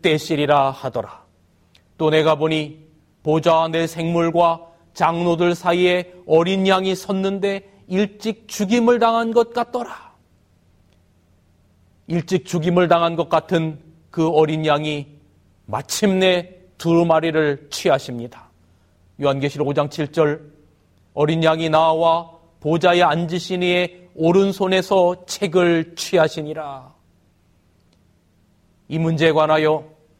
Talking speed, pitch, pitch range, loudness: 215 characters per minute, 160 Hz, 130-180 Hz, -19 LUFS